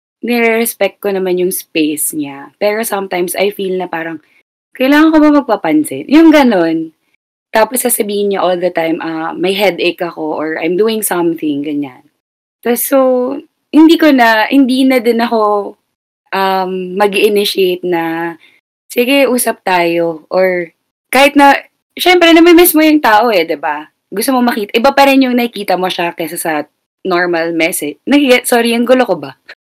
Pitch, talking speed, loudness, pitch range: 200 Hz, 165 wpm, -11 LUFS, 170-250 Hz